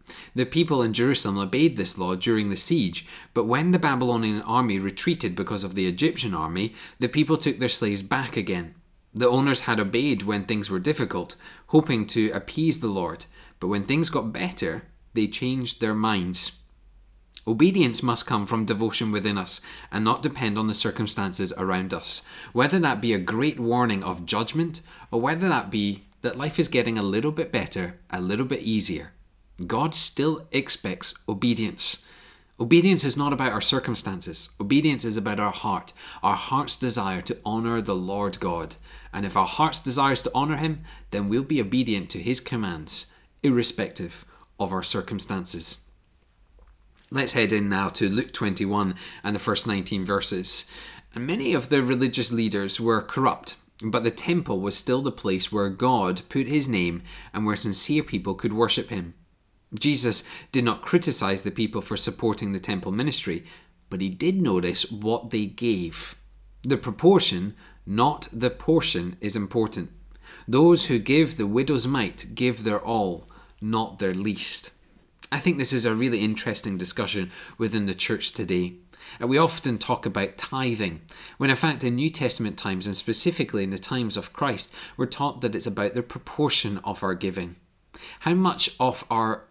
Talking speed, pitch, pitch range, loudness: 170 wpm, 115 Hz, 100-130 Hz, -24 LUFS